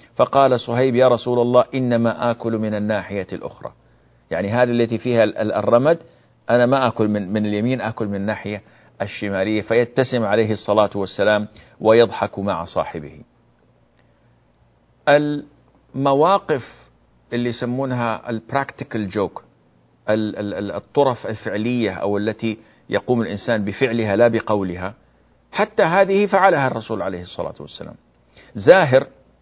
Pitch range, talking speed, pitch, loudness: 105-125 Hz, 110 wpm, 115 Hz, -19 LUFS